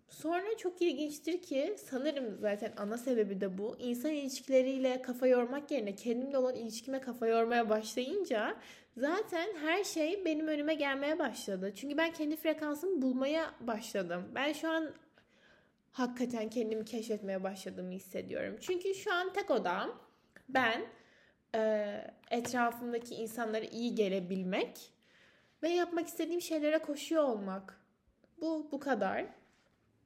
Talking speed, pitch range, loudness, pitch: 120 wpm, 225-315 Hz, -35 LUFS, 260 Hz